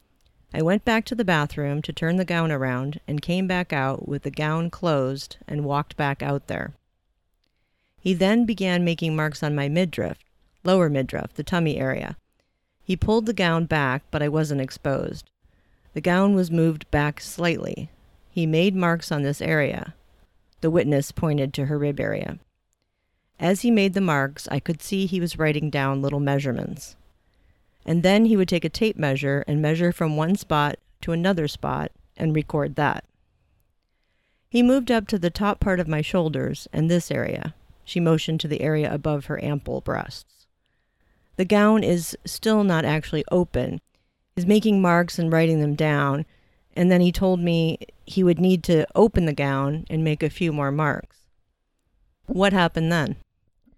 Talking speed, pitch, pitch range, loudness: 175 wpm, 160 Hz, 145-180 Hz, -23 LUFS